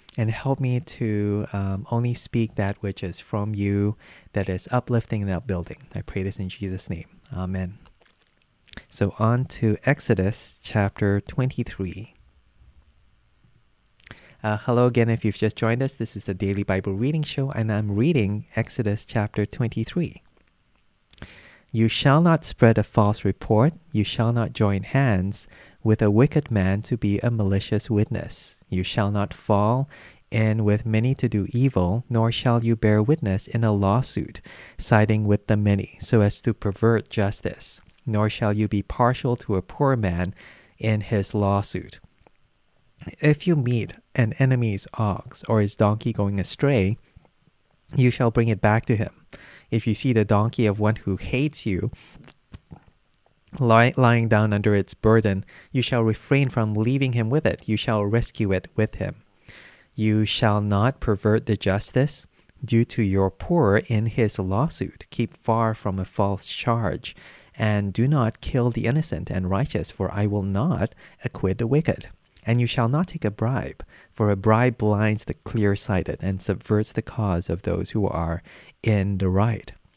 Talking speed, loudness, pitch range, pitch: 165 wpm, -23 LUFS, 100-120 Hz, 110 Hz